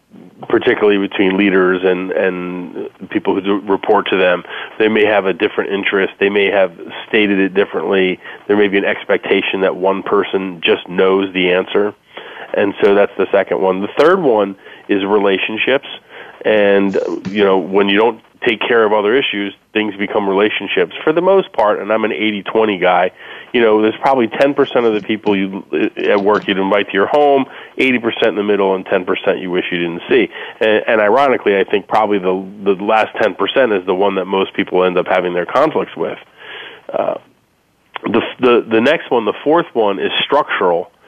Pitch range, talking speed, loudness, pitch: 95-110 Hz, 190 wpm, -14 LUFS, 100 Hz